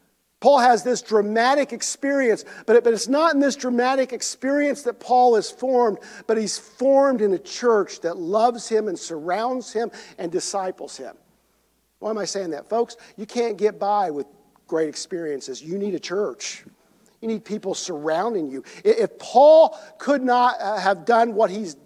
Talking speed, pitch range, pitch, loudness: 175 wpm, 205-250 Hz, 225 Hz, -21 LUFS